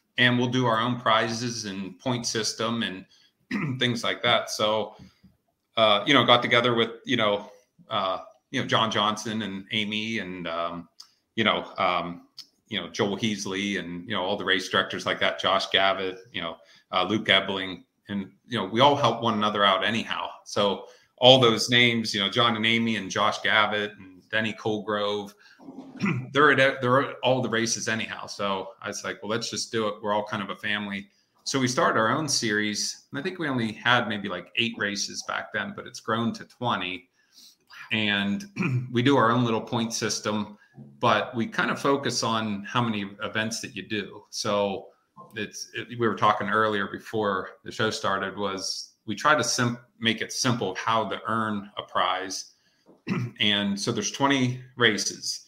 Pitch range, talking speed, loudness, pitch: 100-120 Hz, 190 wpm, -25 LUFS, 110 Hz